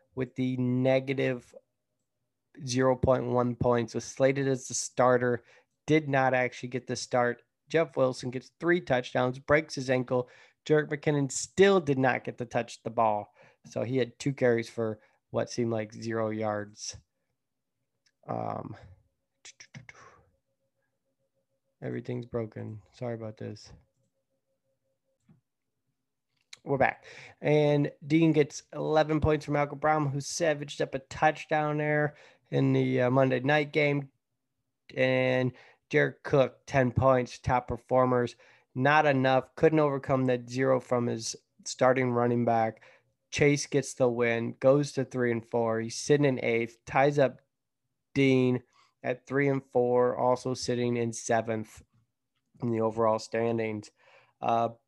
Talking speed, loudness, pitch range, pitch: 130 wpm, -28 LUFS, 120-135 Hz, 130 Hz